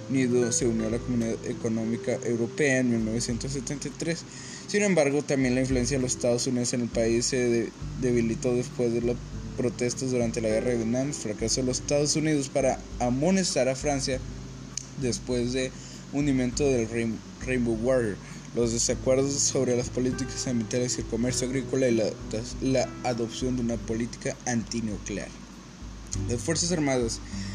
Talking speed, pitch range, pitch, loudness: 150 wpm, 115-130 Hz, 125 Hz, -27 LUFS